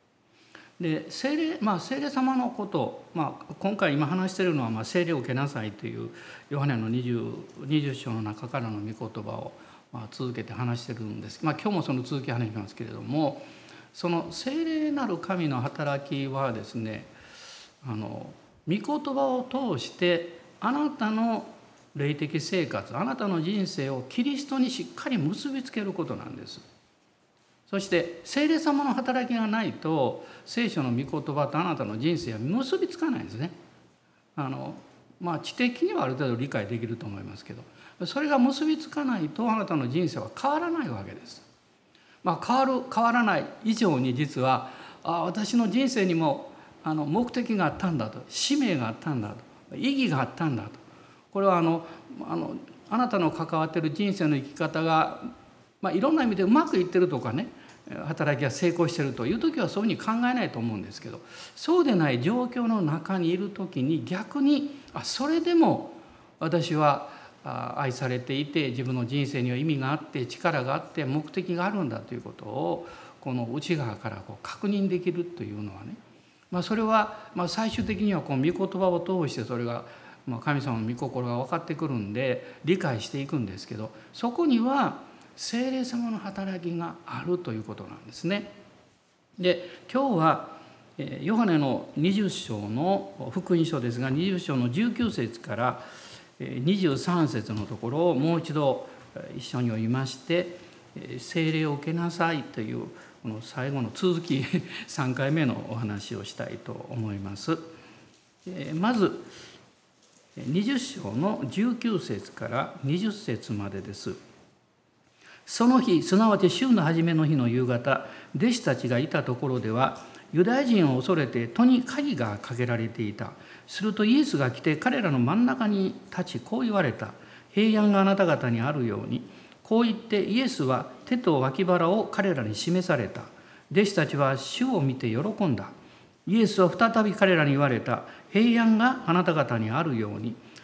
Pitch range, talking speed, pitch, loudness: 130-215 Hz, 320 characters per minute, 165 Hz, -27 LUFS